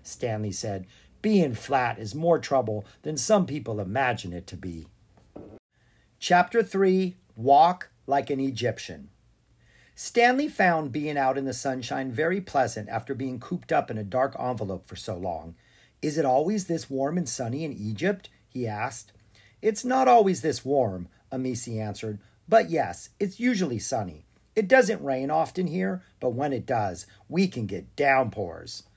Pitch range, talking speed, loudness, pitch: 110-175 Hz, 155 wpm, -26 LUFS, 135 Hz